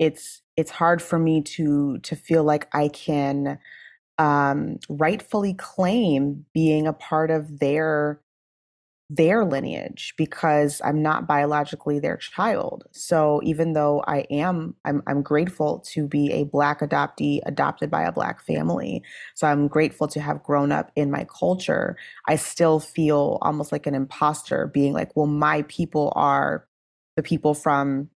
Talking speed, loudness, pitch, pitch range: 150 wpm, -23 LUFS, 150 Hz, 145-160 Hz